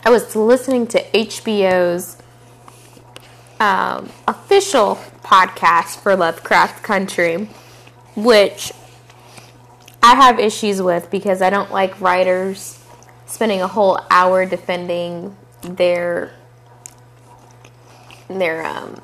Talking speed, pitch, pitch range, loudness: 90 wpm, 175 Hz, 120-195 Hz, -16 LUFS